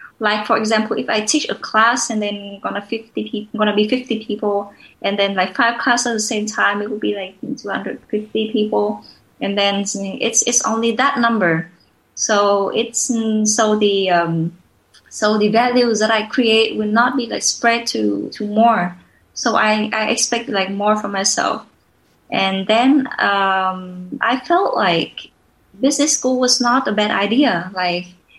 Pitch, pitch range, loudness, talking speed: 215 Hz, 200-235 Hz, -17 LUFS, 175 wpm